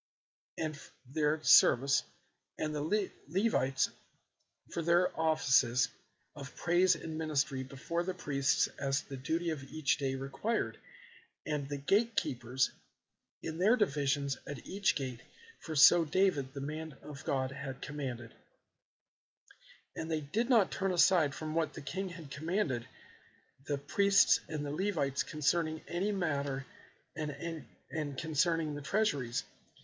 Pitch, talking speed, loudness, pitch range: 155 Hz, 135 wpm, -32 LUFS, 140-175 Hz